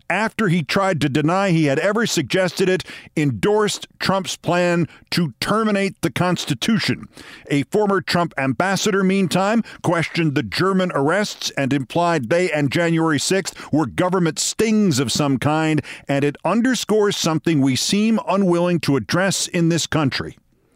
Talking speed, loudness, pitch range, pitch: 145 wpm, -19 LUFS, 150-195 Hz, 170 Hz